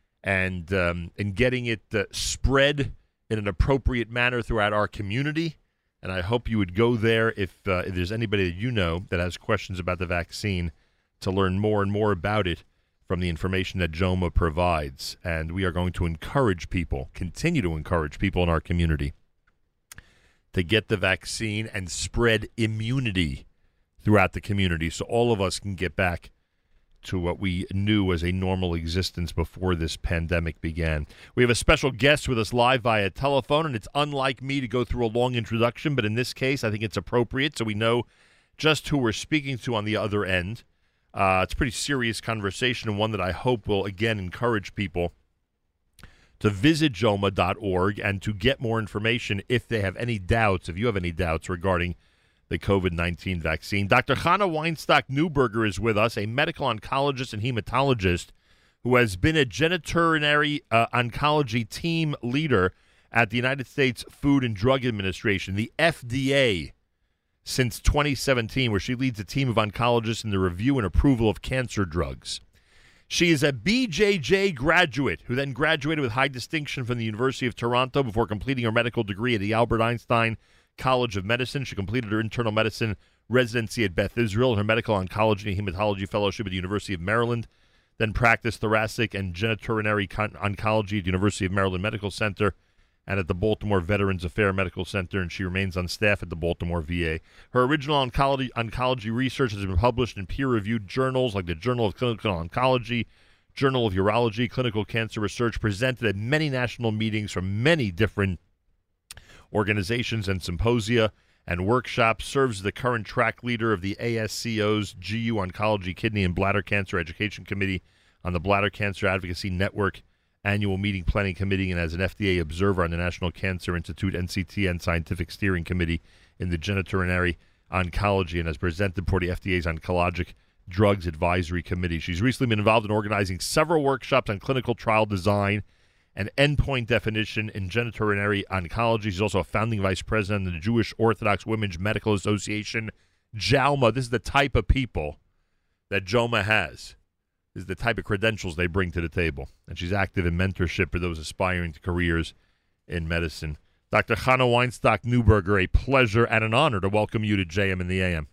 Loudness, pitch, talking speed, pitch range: -25 LUFS, 105 Hz, 175 wpm, 90-120 Hz